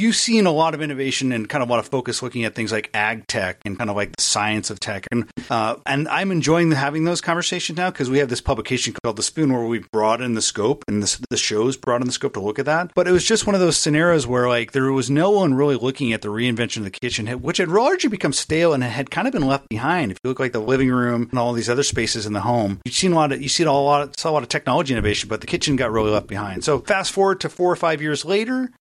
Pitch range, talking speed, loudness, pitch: 115-160 Hz, 300 wpm, -20 LUFS, 130 Hz